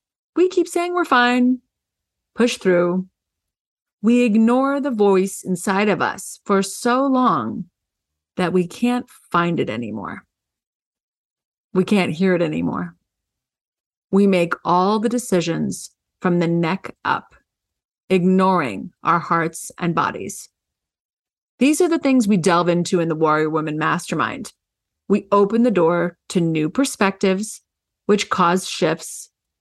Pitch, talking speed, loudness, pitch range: 195 Hz, 130 wpm, -19 LUFS, 175-240 Hz